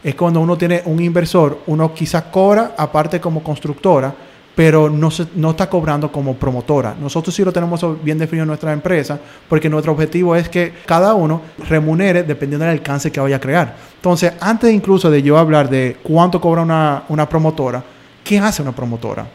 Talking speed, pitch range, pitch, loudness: 185 wpm, 150-175 Hz, 160 Hz, -15 LUFS